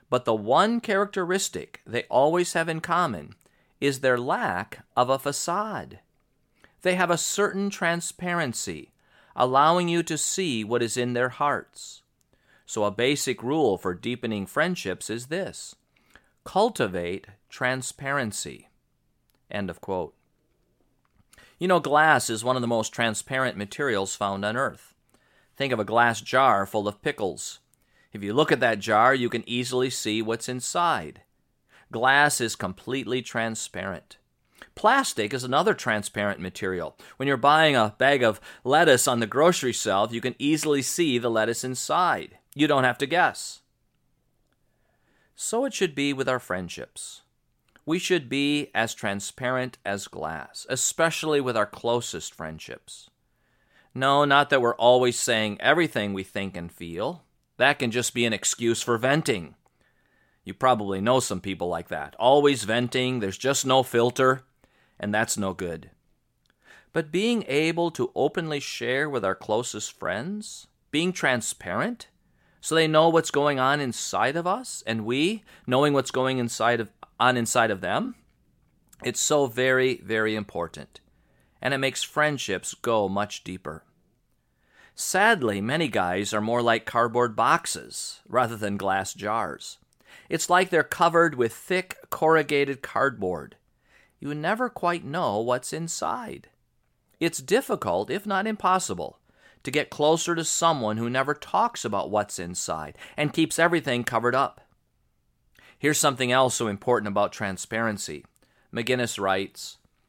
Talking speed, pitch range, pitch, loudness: 140 wpm, 110-155 Hz, 130 Hz, -25 LUFS